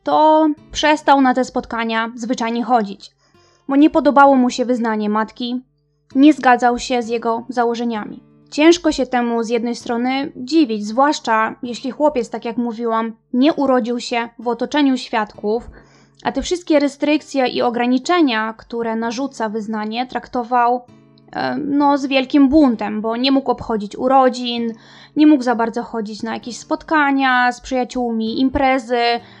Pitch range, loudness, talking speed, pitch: 230-275 Hz, -17 LUFS, 145 wpm, 245 Hz